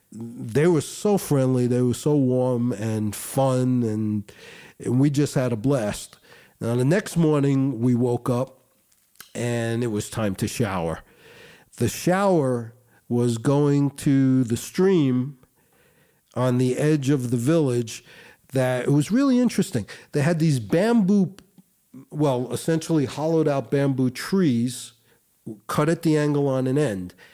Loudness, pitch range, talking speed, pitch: -23 LUFS, 120-150 Hz, 145 wpm, 130 Hz